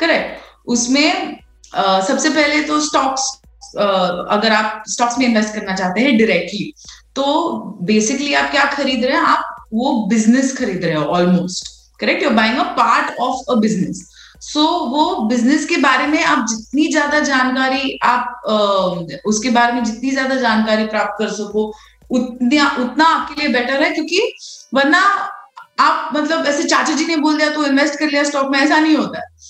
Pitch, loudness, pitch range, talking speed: 265 Hz, -16 LUFS, 220-300 Hz, 175 wpm